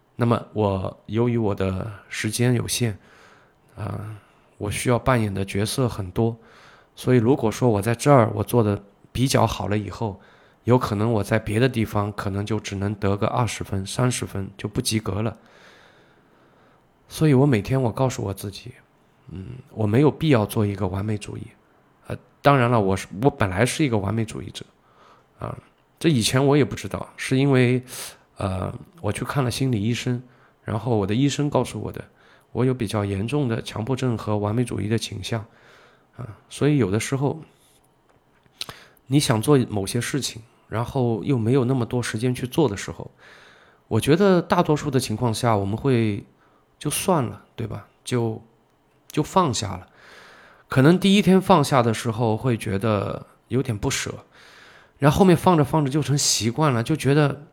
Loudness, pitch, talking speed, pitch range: -22 LUFS, 115 Hz, 255 characters per minute, 105-135 Hz